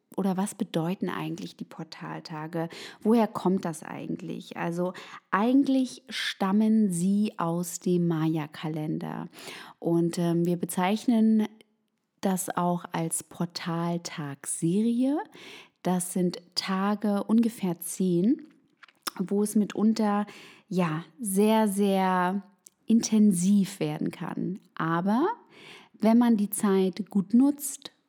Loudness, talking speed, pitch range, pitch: -27 LUFS, 100 wpm, 175-220 Hz, 195 Hz